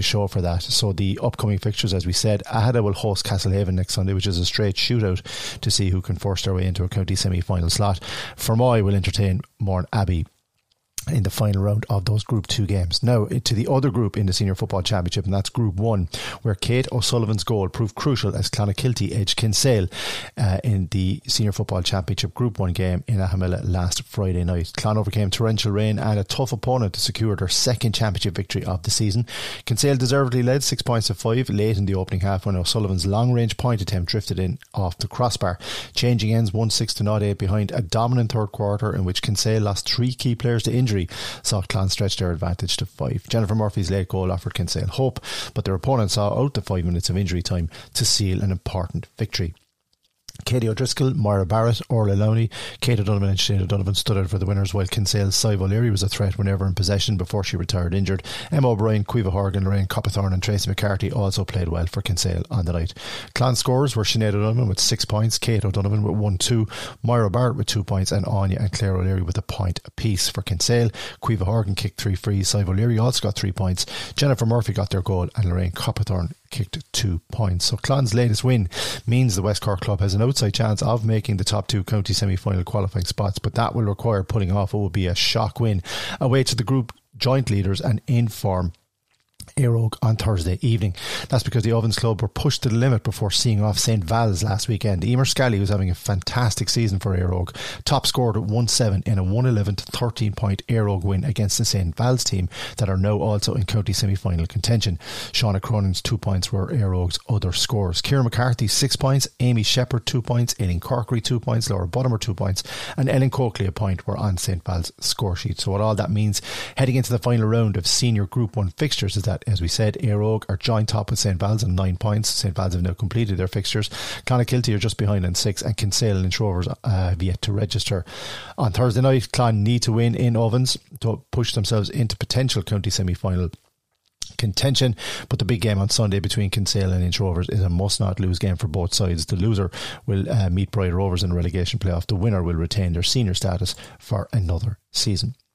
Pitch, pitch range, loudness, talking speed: 105 Hz, 95-120 Hz, -22 LUFS, 215 wpm